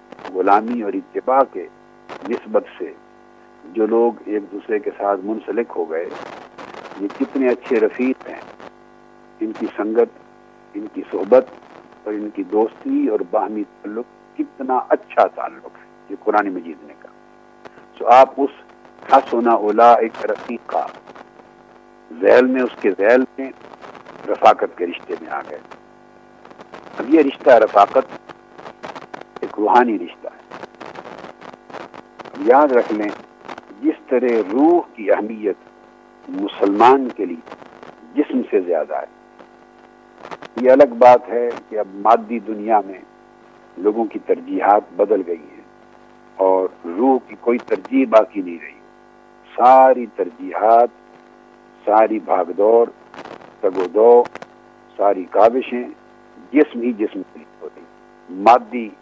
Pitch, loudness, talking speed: 130 Hz, -17 LUFS, 125 wpm